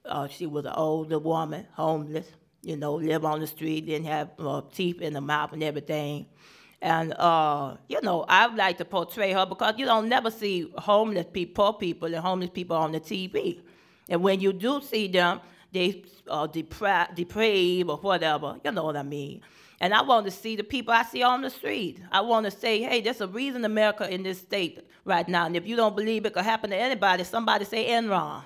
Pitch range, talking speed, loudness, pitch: 160-215 Hz, 215 wpm, -26 LUFS, 180 Hz